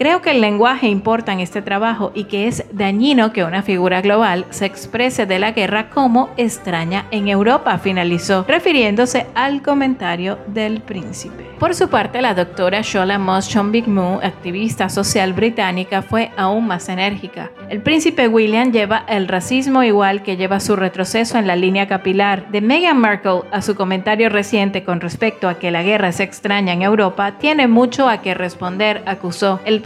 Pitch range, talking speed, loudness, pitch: 190-225 Hz, 175 wpm, -16 LUFS, 205 Hz